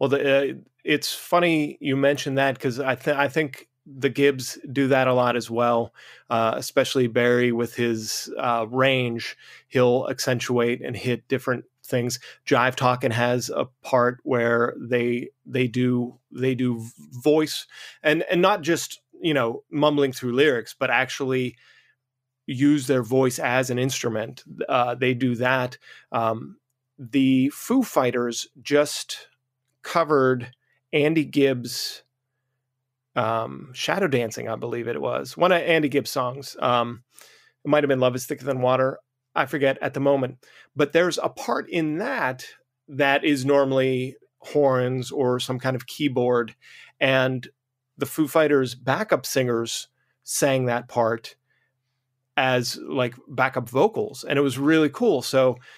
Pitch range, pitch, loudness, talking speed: 125-140 Hz, 130 Hz, -23 LUFS, 145 wpm